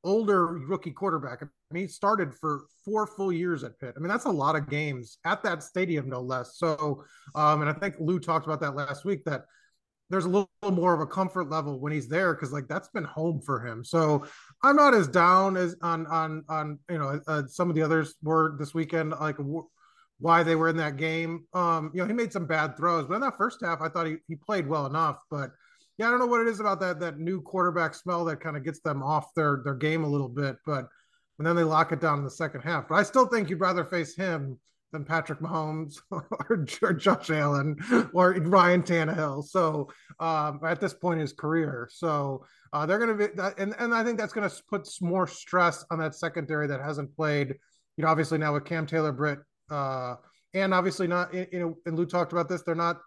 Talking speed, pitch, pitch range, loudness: 235 wpm, 165 Hz, 150-180 Hz, -28 LUFS